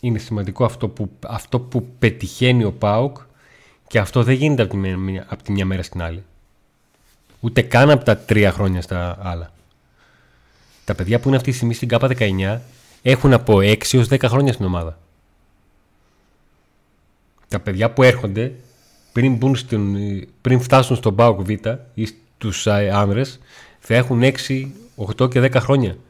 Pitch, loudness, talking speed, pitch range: 110 Hz, -18 LUFS, 155 wpm, 100-125 Hz